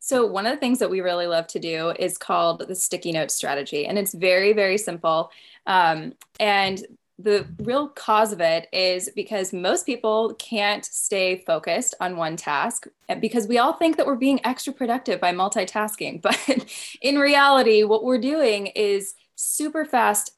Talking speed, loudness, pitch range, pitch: 175 wpm, -22 LUFS, 185-245 Hz, 210 Hz